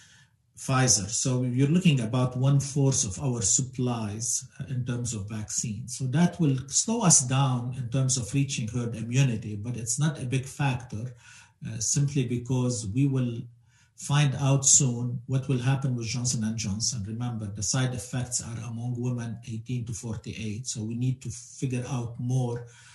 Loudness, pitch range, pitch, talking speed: -27 LUFS, 115-135 Hz, 125 Hz, 170 wpm